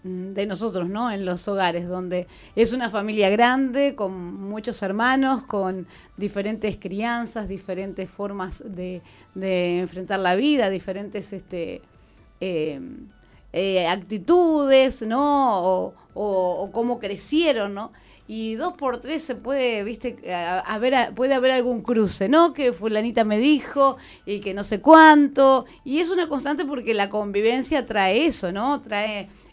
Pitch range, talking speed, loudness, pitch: 190-255 Hz, 150 wpm, -22 LUFS, 215 Hz